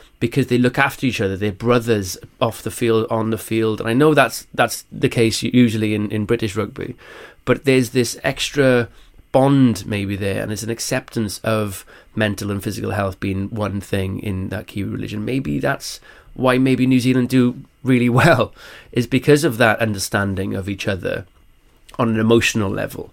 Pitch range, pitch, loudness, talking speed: 105-125 Hz, 115 Hz, -19 LUFS, 180 wpm